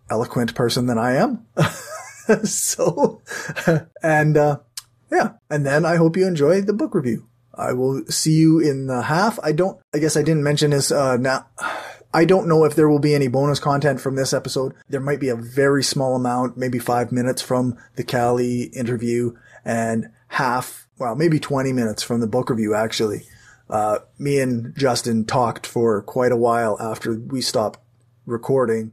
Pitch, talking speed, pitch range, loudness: 130 Hz, 180 wpm, 120-150 Hz, -20 LUFS